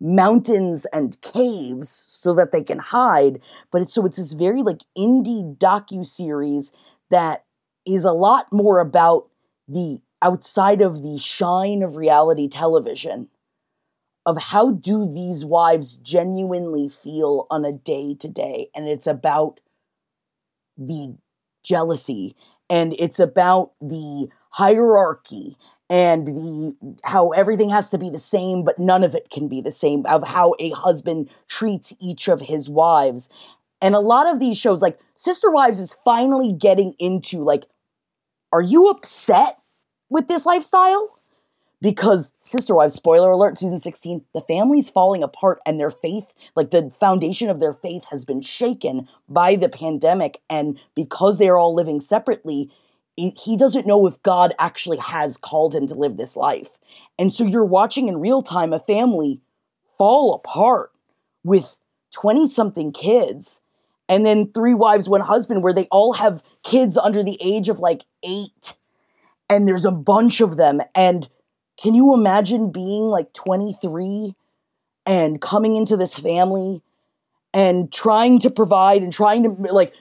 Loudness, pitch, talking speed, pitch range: -18 LUFS, 185 Hz, 150 wpm, 160-210 Hz